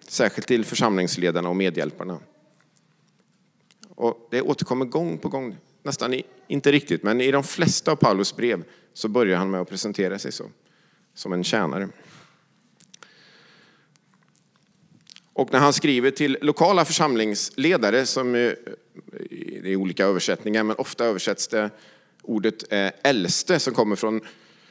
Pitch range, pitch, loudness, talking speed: 100-150 Hz, 120 Hz, -23 LUFS, 130 wpm